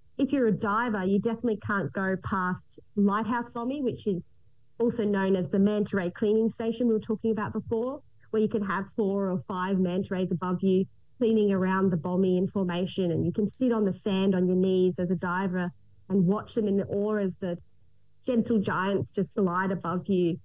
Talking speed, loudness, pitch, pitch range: 205 wpm, -28 LUFS, 195 Hz, 185-220 Hz